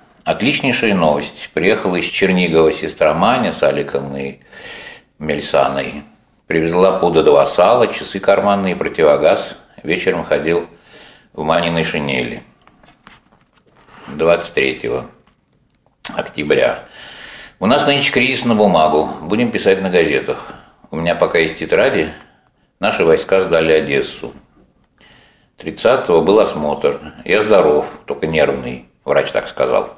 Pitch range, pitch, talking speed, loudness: 70-95 Hz, 80 Hz, 110 wpm, -15 LUFS